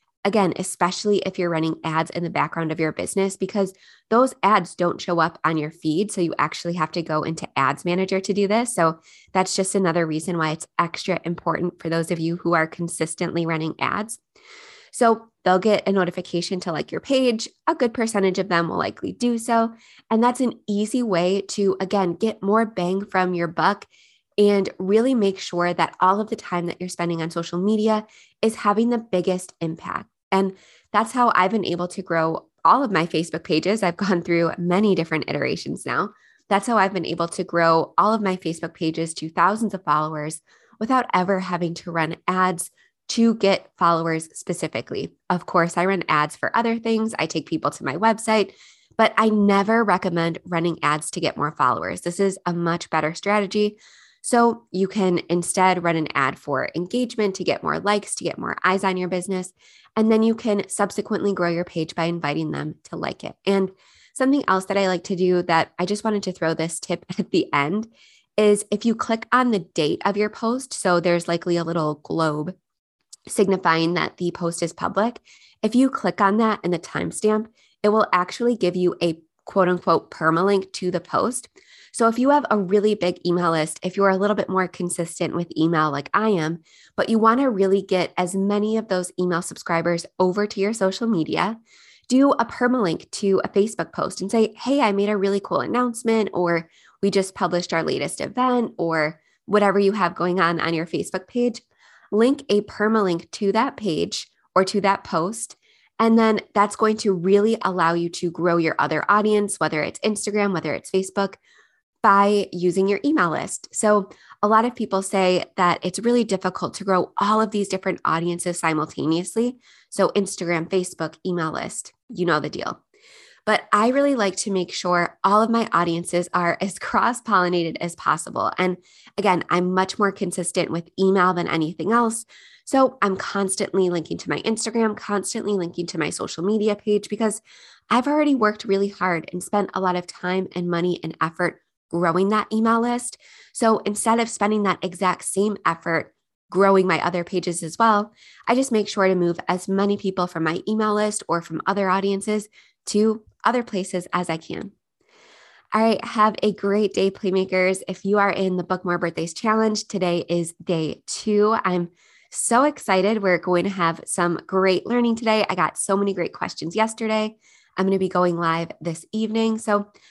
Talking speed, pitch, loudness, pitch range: 195 wpm, 190 Hz, -22 LUFS, 170-210 Hz